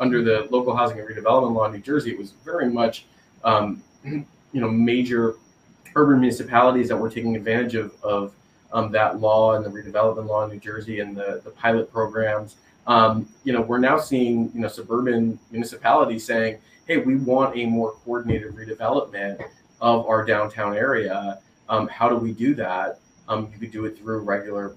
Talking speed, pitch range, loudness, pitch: 185 wpm, 110-120 Hz, -22 LUFS, 110 Hz